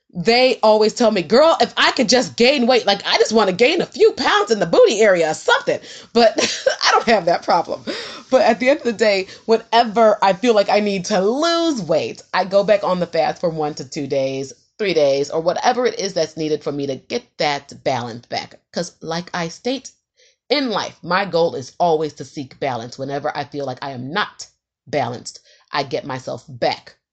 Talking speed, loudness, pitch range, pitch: 220 wpm, -18 LUFS, 160-245 Hz, 205 Hz